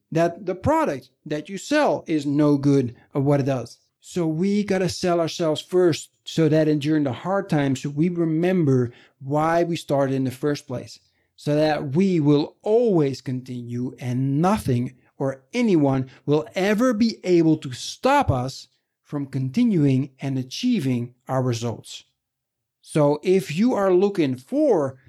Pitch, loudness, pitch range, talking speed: 145 Hz, -22 LUFS, 130-175 Hz, 155 wpm